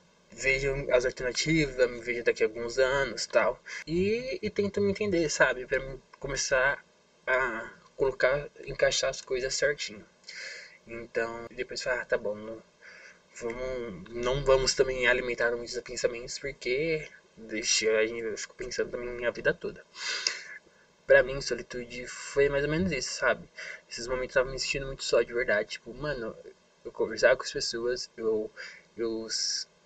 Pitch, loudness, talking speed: 135 Hz, -29 LUFS, 150 wpm